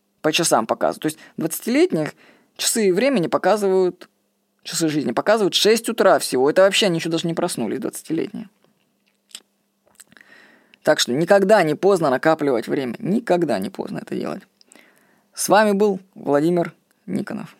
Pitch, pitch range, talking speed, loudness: 185 Hz, 160-215 Hz, 135 wpm, -19 LUFS